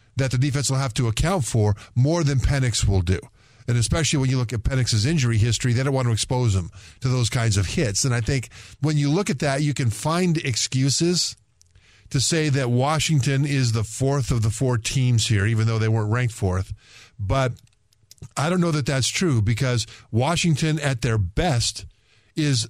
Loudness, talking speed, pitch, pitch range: -22 LUFS, 200 wpm, 125 Hz, 110-140 Hz